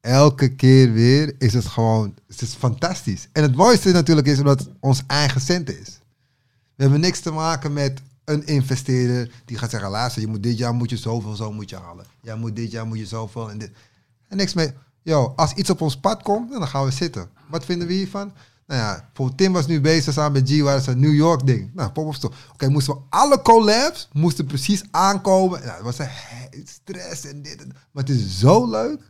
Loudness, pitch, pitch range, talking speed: -19 LUFS, 135 Hz, 120-160 Hz, 225 wpm